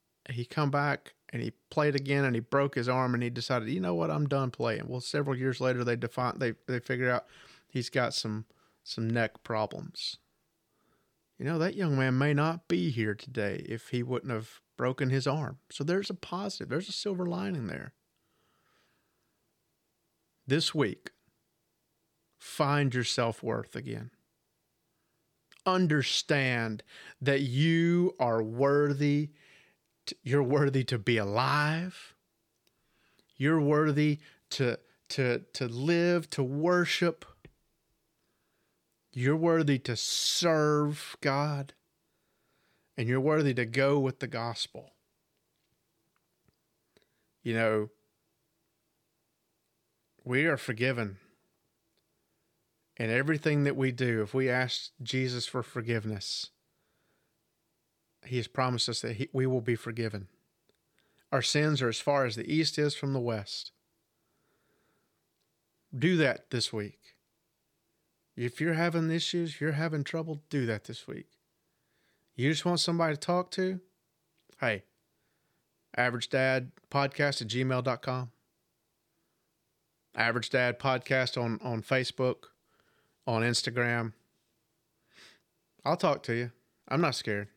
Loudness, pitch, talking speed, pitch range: -30 LUFS, 130 Hz, 125 wpm, 120-150 Hz